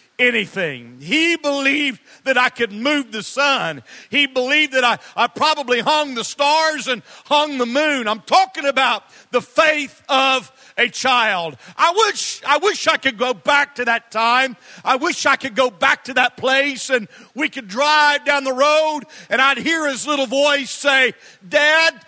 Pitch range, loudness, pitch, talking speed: 245-295 Hz, -17 LUFS, 275 Hz, 175 wpm